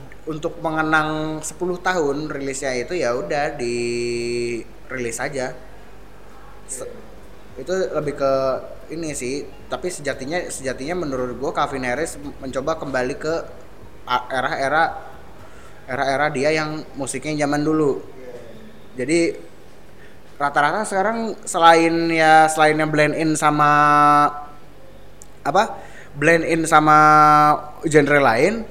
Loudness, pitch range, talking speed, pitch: -19 LUFS, 130-155 Hz, 105 wpm, 145 Hz